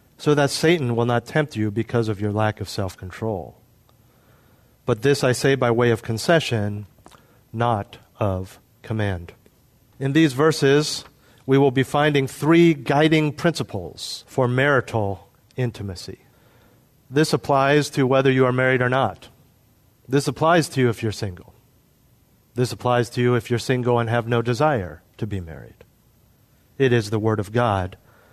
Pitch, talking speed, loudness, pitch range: 120 Hz, 155 wpm, -21 LUFS, 110-135 Hz